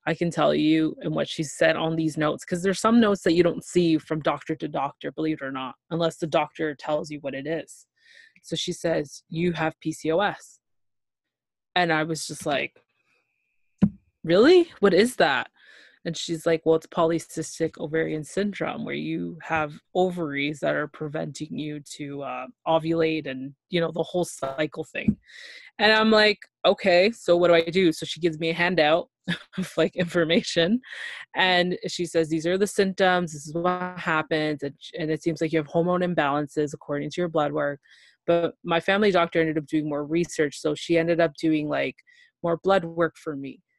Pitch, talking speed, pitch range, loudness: 165 Hz, 190 wpm, 155-180 Hz, -24 LUFS